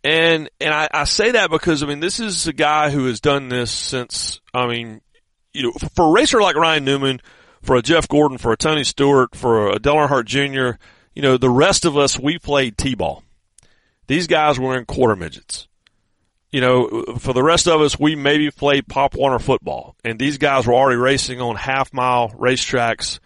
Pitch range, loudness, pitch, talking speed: 125-150 Hz, -17 LUFS, 135 Hz, 205 wpm